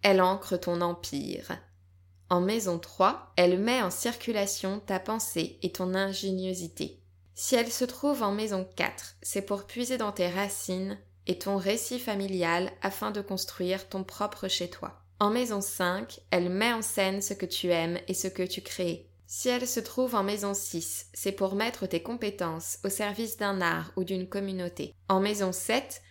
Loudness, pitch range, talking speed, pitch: -30 LUFS, 180-205 Hz, 175 wpm, 190 Hz